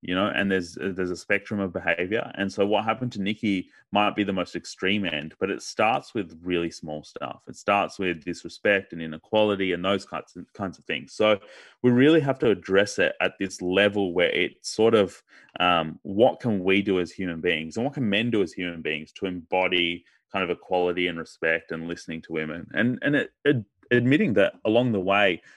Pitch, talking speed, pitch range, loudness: 95 Hz, 210 wpm, 90-105 Hz, -25 LUFS